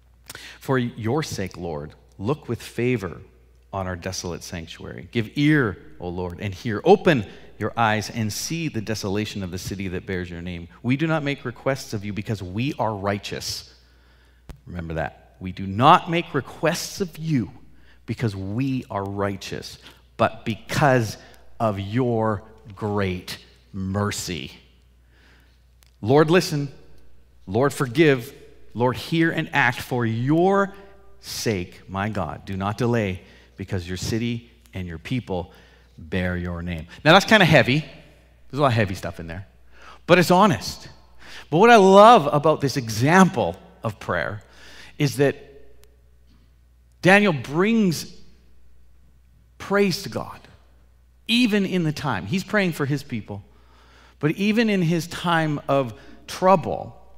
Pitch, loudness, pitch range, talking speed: 110 Hz, -22 LUFS, 85-145 Hz, 140 wpm